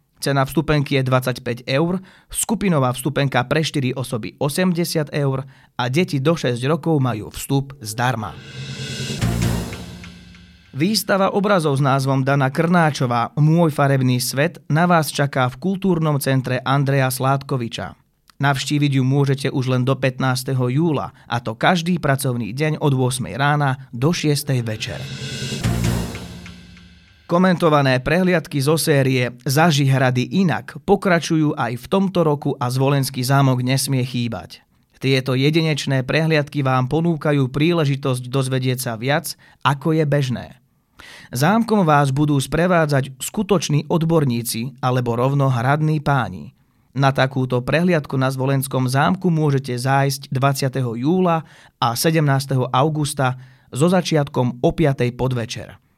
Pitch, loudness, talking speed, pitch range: 135 Hz, -19 LUFS, 120 wpm, 125-155 Hz